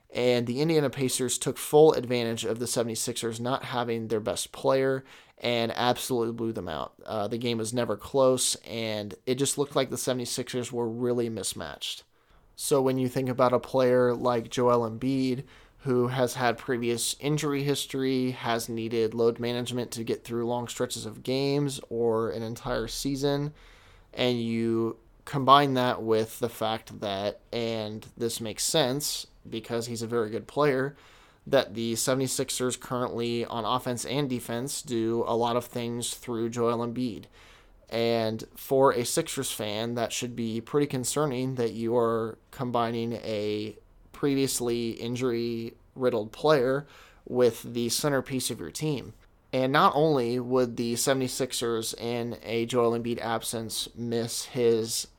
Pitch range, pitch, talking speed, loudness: 115-130 Hz, 120 Hz, 150 wpm, -28 LUFS